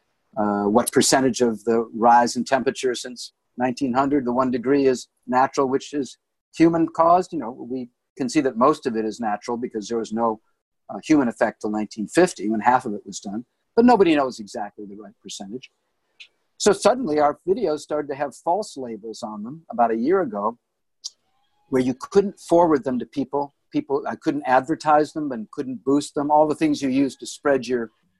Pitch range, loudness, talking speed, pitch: 115-150 Hz, -22 LUFS, 195 wpm, 130 Hz